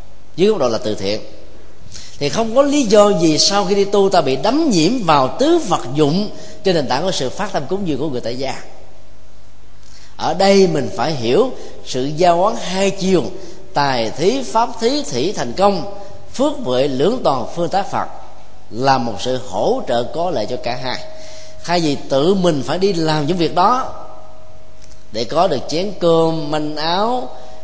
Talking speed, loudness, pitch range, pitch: 190 wpm, -17 LUFS, 125-195 Hz, 155 Hz